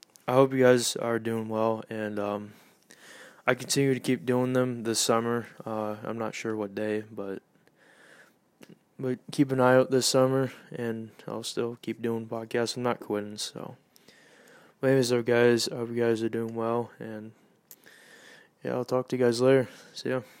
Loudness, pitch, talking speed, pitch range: -28 LUFS, 115 Hz, 180 wpm, 110-125 Hz